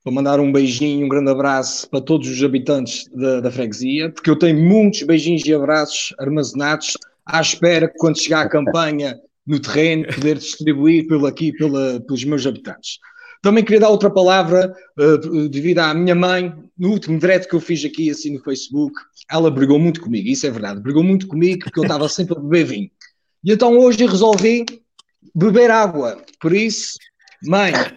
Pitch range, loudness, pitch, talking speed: 145-185 Hz, -16 LUFS, 160 Hz, 180 wpm